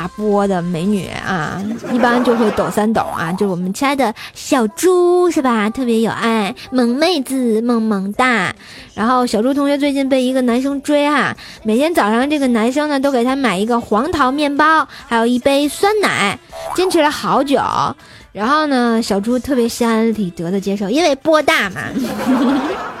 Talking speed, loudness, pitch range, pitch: 260 characters per minute, -15 LUFS, 215-285 Hz, 250 Hz